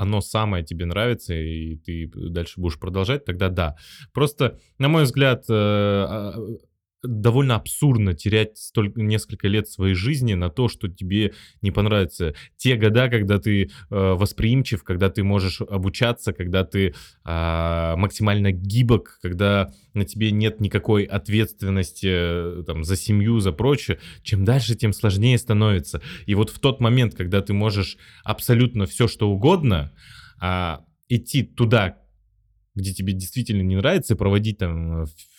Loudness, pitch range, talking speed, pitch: -22 LUFS, 95-115 Hz, 140 wpm, 100 Hz